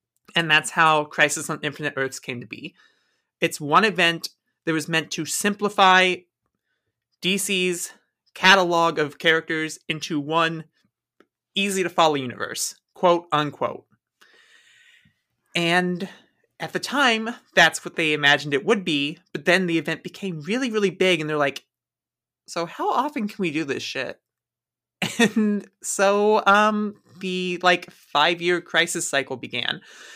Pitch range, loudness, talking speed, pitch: 160-195 Hz, -21 LUFS, 140 wpm, 170 Hz